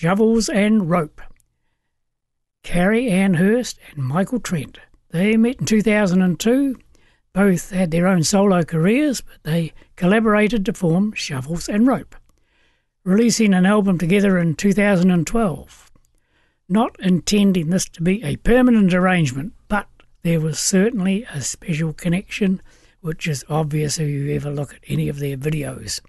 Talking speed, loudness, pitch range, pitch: 140 wpm, -19 LUFS, 160-210 Hz, 185 Hz